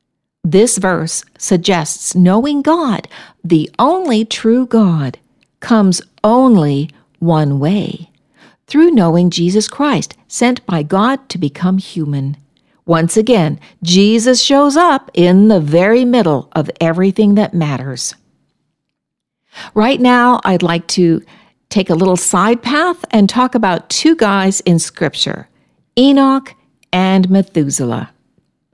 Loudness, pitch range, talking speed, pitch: -12 LUFS, 170-240 Hz, 115 wpm, 195 Hz